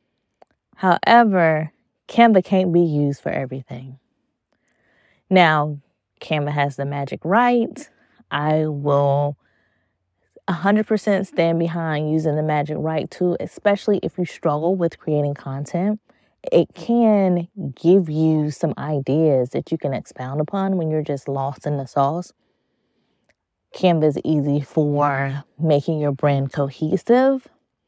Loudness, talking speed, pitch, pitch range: -20 LUFS, 120 wpm, 155 Hz, 145-180 Hz